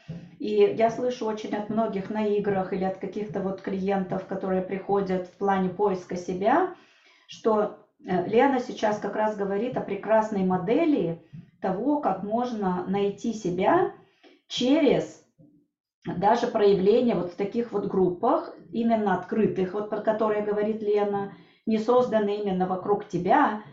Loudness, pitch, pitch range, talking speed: -26 LUFS, 205 Hz, 190-225 Hz, 135 wpm